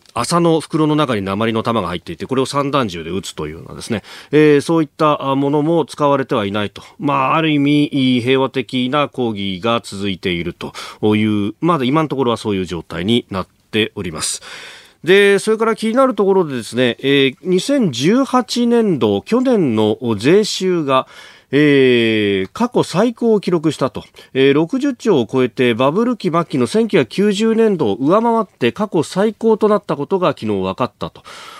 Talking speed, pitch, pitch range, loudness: 330 characters per minute, 145 Hz, 115-195 Hz, -16 LUFS